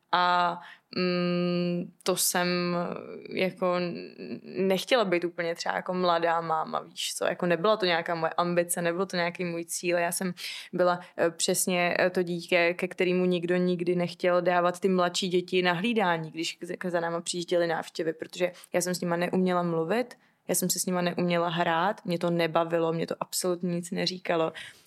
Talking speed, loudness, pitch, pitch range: 165 wpm, -28 LUFS, 175 Hz, 170-180 Hz